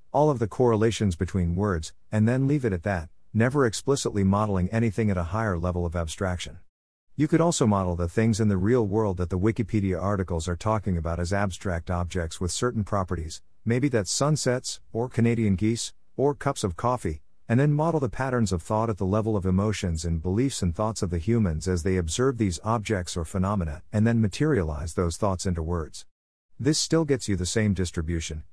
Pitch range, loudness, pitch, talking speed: 90-115 Hz, -26 LUFS, 100 Hz, 200 wpm